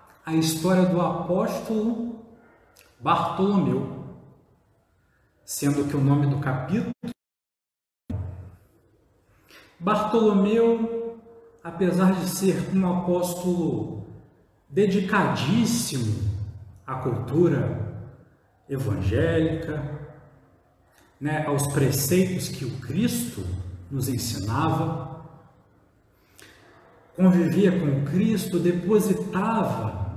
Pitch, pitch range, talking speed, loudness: 160 Hz, 115-185 Hz, 70 wpm, -24 LUFS